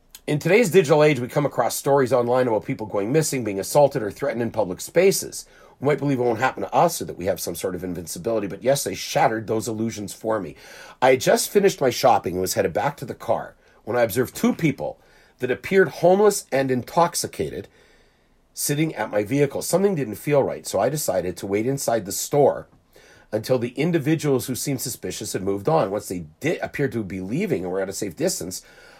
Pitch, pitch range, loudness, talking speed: 130 Hz, 105-145 Hz, -22 LUFS, 215 wpm